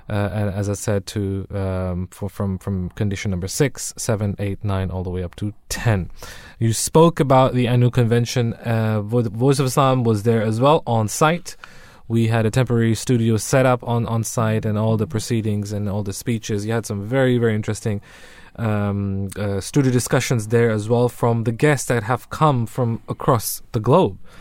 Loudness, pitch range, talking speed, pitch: -20 LUFS, 100-125 Hz, 190 wpm, 115 Hz